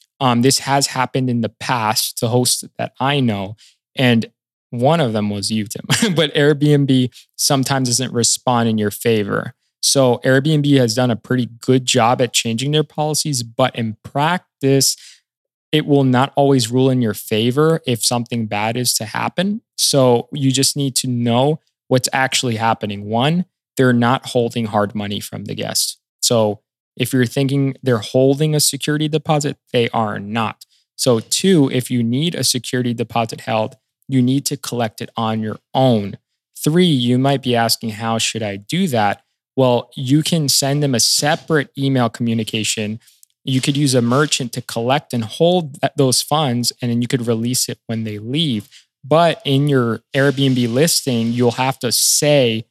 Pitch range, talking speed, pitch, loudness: 115-140 Hz, 170 wpm, 125 Hz, -17 LUFS